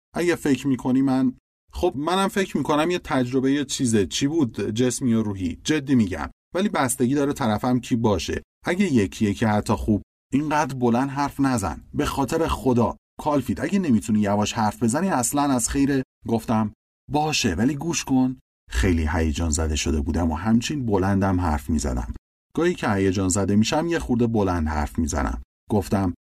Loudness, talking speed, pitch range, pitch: -23 LUFS, 165 wpm, 95-140 Hz, 120 Hz